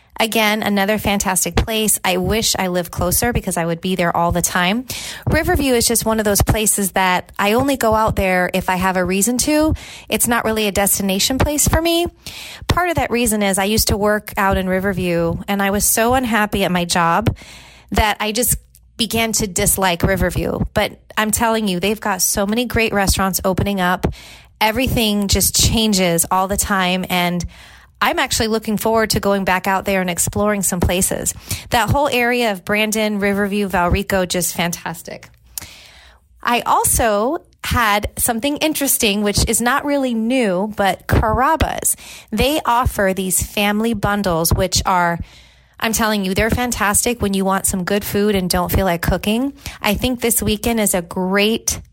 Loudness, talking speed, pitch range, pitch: -17 LUFS, 180 wpm, 185-225 Hz, 205 Hz